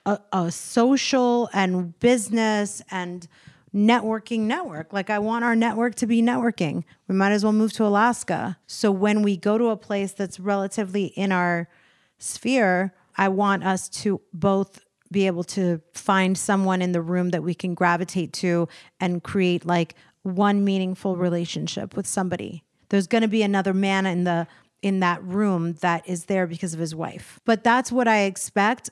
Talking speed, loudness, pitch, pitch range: 175 wpm, -23 LUFS, 195 Hz, 180-215 Hz